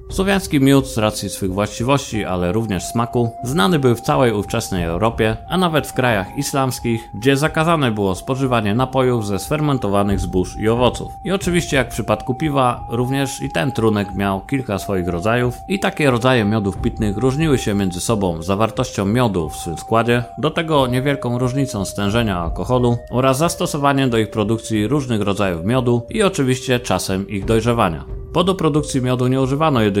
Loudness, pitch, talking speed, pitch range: -18 LUFS, 120 Hz, 170 wpm, 100-135 Hz